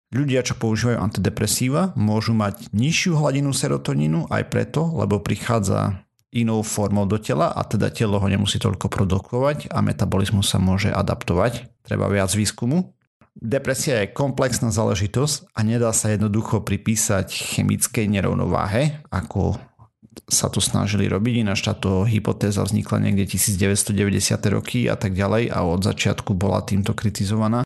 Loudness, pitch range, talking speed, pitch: -21 LUFS, 100-120 Hz, 140 wpm, 110 Hz